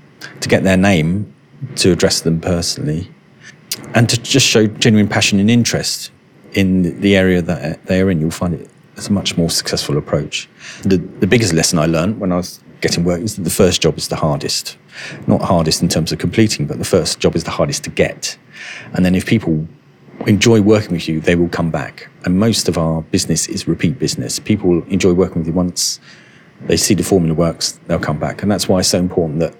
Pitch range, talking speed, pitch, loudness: 85-105 Hz, 215 wpm, 95 Hz, -15 LUFS